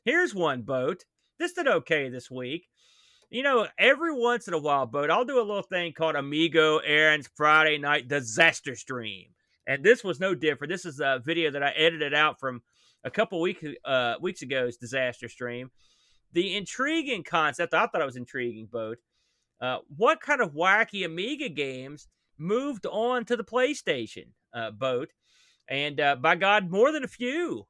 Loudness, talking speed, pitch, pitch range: -26 LUFS, 175 wpm, 155 Hz, 130-200 Hz